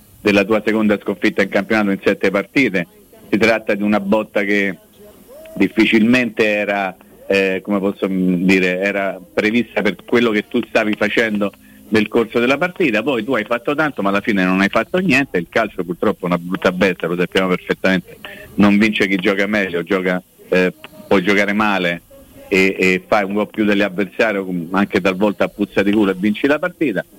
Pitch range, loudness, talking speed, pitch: 95-110 Hz, -17 LUFS, 180 wpm, 100 Hz